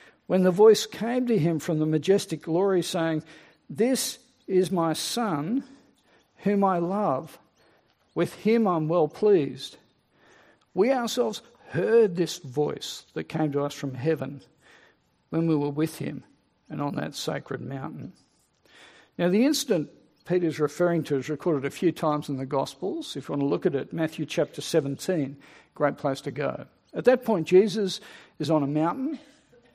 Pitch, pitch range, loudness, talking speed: 170 Hz, 155-215 Hz, -26 LUFS, 160 wpm